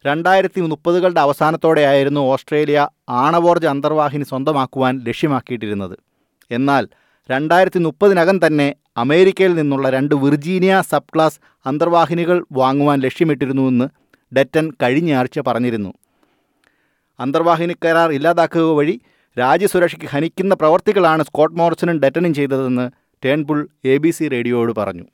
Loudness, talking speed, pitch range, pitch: -16 LUFS, 95 wpm, 135-170 Hz, 150 Hz